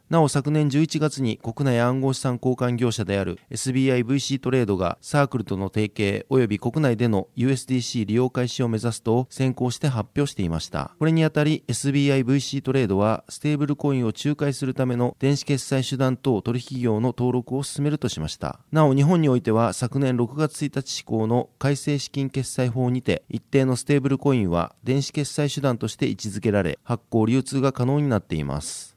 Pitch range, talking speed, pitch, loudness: 115-140 Hz, 390 characters per minute, 130 Hz, -23 LUFS